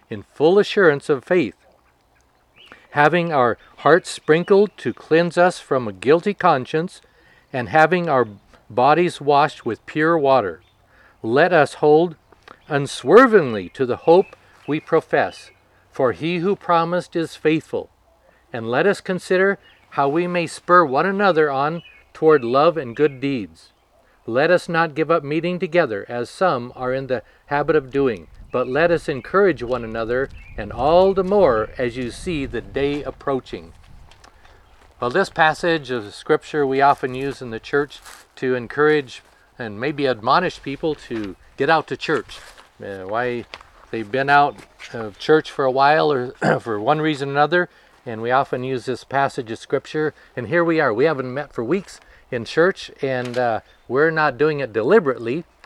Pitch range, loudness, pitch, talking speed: 125-170 Hz, -19 LUFS, 145 Hz, 160 wpm